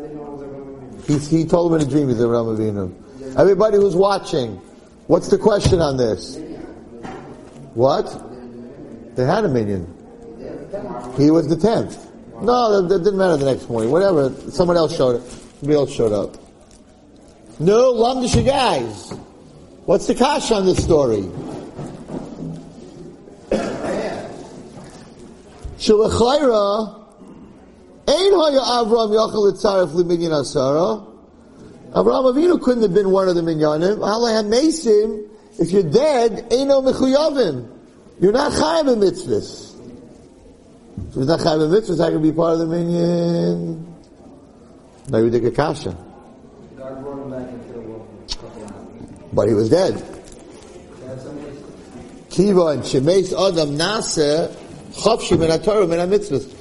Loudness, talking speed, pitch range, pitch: -17 LUFS, 120 wpm, 135-215 Hz, 170 Hz